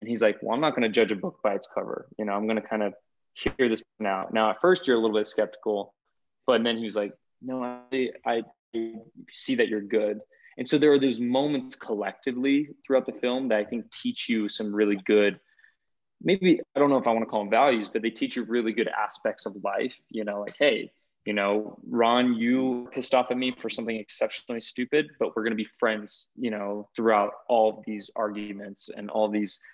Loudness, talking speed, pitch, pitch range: -27 LUFS, 230 wpm, 115 Hz, 105-130 Hz